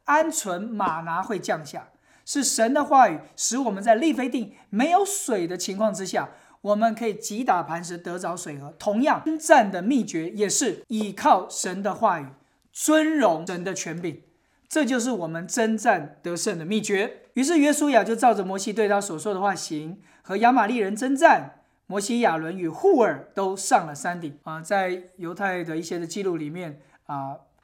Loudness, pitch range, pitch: -24 LUFS, 175-250 Hz, 205 Hz